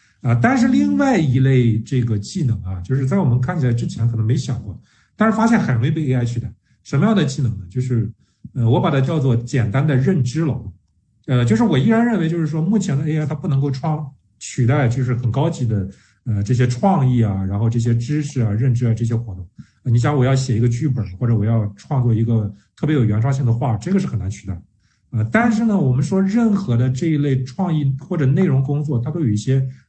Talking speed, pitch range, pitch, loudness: 335 characters per minute, 115-150 Hz, 130 Hz, -18 LUFS